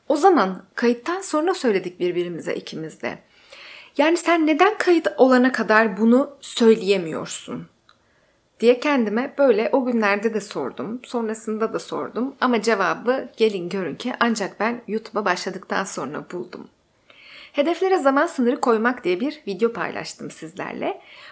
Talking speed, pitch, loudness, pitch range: 130 wpm, 240 Hz, -21 LUFS, 215-280 Hz